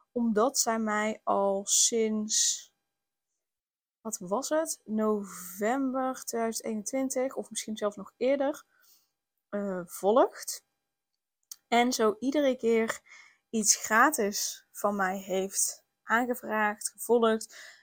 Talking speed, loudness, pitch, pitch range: 95 wpm, -28 LUFS, 225 Hz, 210-255 Hz